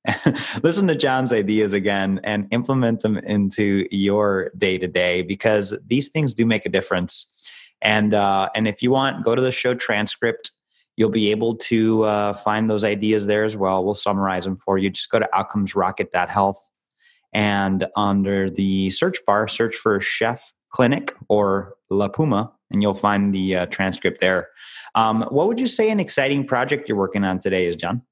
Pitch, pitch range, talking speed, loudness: 105 Hz, 95-115 Hz, 175 wpm, -20 LUFS